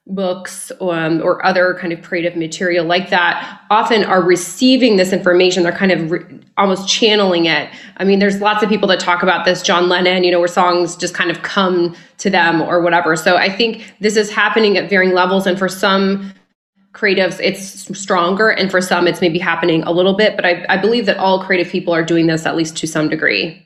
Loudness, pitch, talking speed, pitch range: -14 LUFS, 185 Hz, 220 wpm, 175-195 Hz